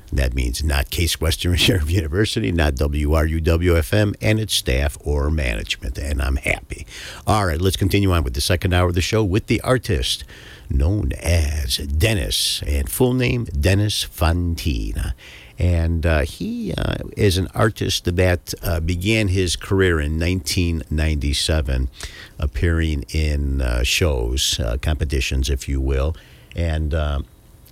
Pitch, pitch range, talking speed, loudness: 85 Hz, 75-95 Hz, 140 wpm, -20 LUFS